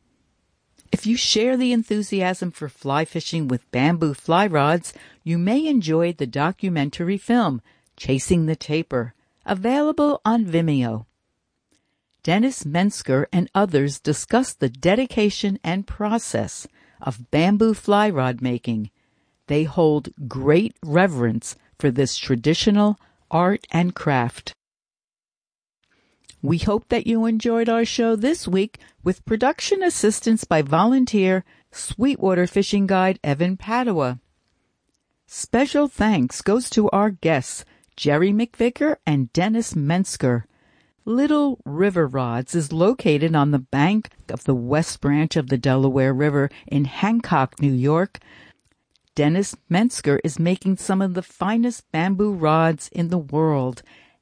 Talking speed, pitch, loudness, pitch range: 125 wpm, 175 Hz, -21 LUFS, 145-210 Hz